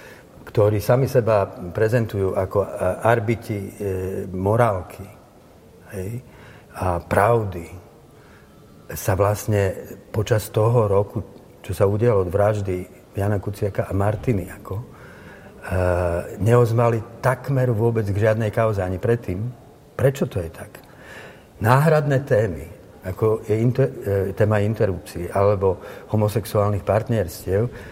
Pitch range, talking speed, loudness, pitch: 95-115 Hz, 105 wpm, -21 LUFS, 105 Hz